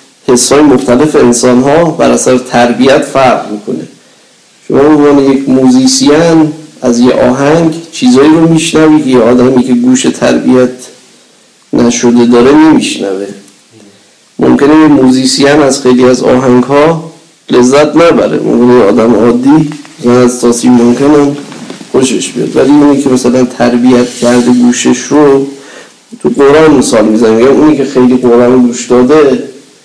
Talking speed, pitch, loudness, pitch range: 125 wpm, 130 Hz, -6 LUFS, 125-145 Hz